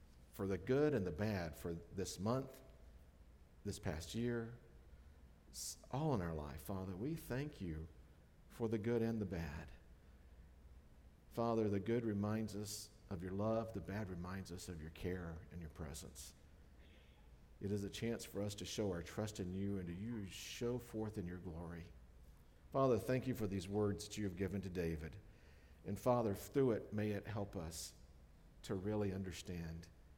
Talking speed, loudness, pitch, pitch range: 175 wpm, -43 LUFS, 95 Hz, 75-105 Hz